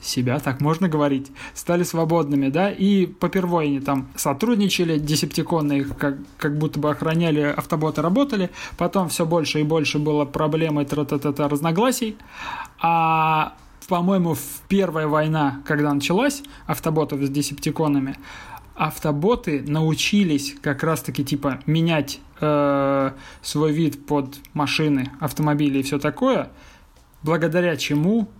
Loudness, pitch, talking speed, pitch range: -22 LUFS, 155 Hz, 120 wpm, 145-170 Hz